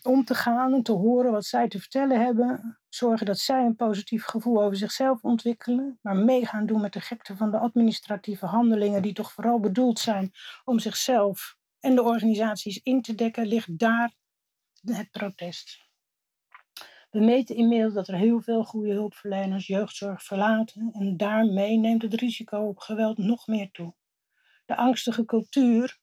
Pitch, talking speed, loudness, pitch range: 225 Hz, 165 wpm, -25 LUFS, 210-240 Hz